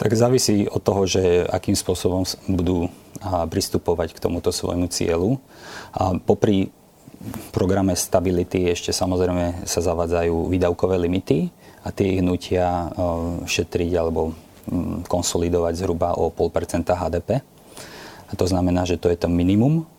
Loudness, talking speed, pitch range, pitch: -22 LUFS, 125 wpm, 85-100 Hz, 90 Hz